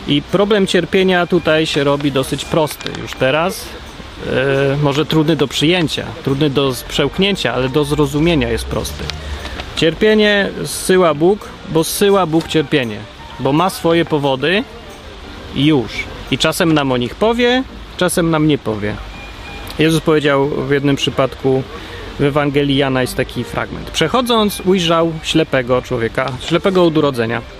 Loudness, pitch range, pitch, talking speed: -15 LUFS, 130-165 Hz, 145 Hz, 140 wpm